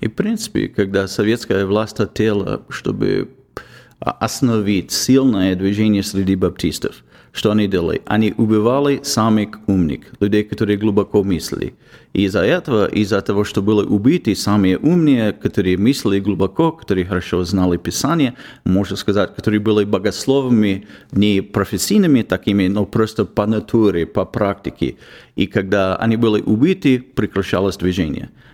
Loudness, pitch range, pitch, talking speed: -17 LUFS, 95-110 Hz, 105 Hz, 130 wpm